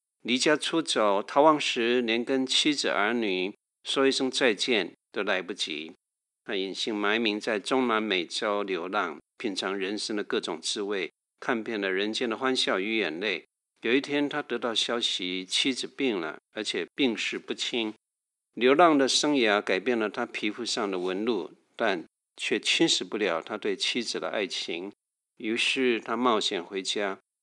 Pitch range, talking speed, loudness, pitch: 105-135 Hz, 235 characters per minute, -27 LUFS, 120 Hz